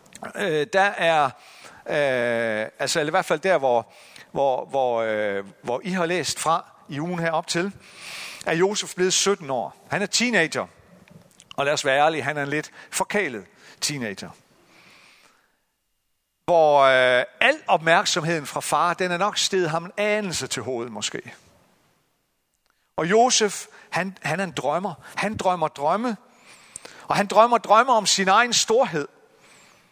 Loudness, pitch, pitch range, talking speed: -22 LUFS, 175 Hz, 145-200 Hz, 145 wpm